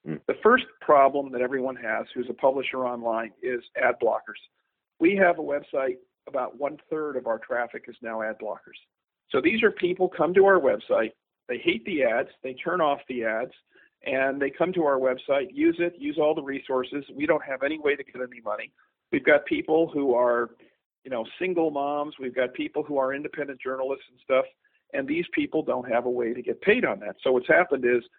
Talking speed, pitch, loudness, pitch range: 210 wpm, 140 Hz, -26 LUFS, 130-180 Hz